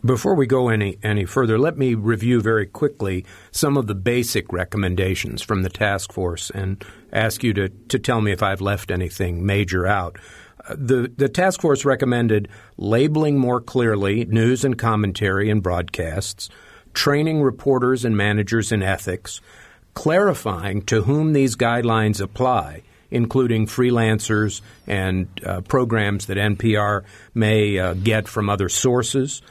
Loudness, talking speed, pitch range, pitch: -20 LUFS, 145 wpm, 100-125 Hz, 110 Hz